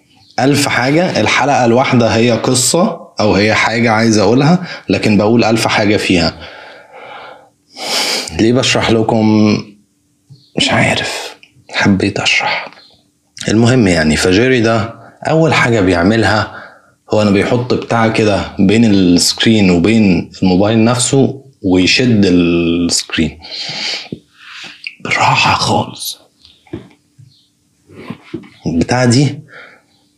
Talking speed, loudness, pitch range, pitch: 90 wpm, -12 LUFS, 95-125 Hz, 110 Hz